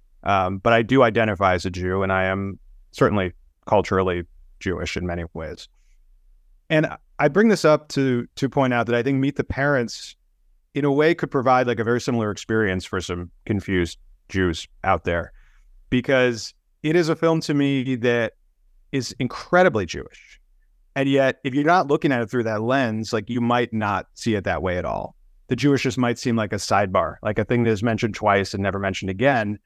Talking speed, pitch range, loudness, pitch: 200 wpm, 95-135 Hz, -22 LUFS, 110 Hz